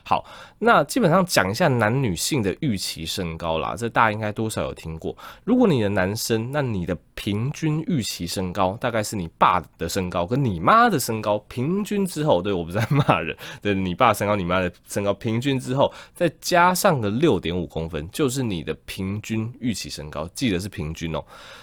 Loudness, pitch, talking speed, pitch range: -23 LUFS, 105 Hz, 295 characters per minute, 90-140 Hz